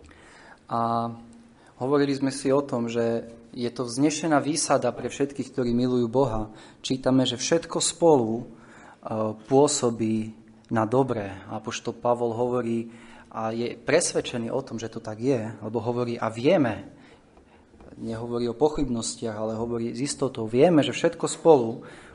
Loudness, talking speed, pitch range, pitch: -25 LUFS, 140 wpm, 115-135 Hz, 120 Hz